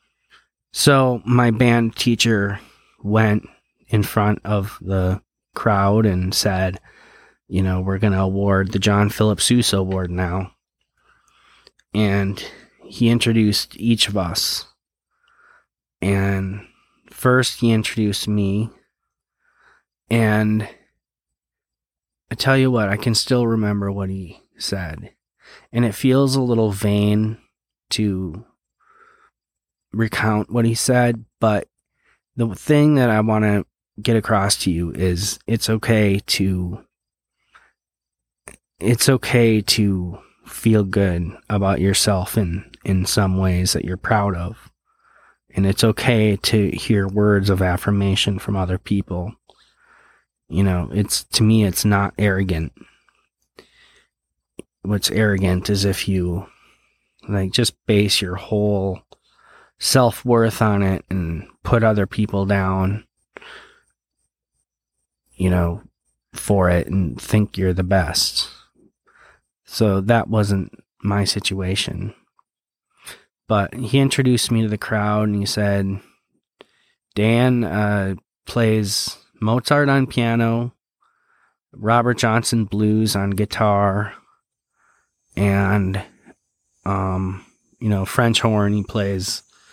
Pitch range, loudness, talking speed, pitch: 95-110 Hz, -19 LUFS, 115 wpm, 105 Hz